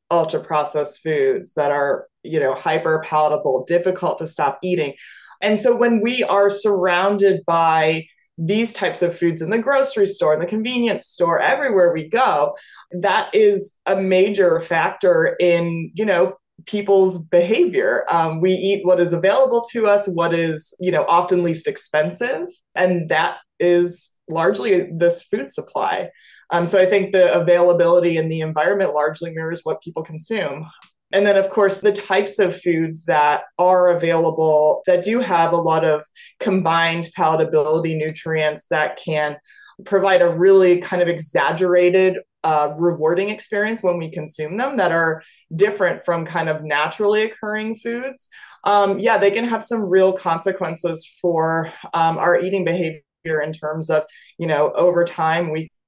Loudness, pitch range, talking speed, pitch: -18 LUFS, 160-200 Hz, 155 wpm, 175 Hz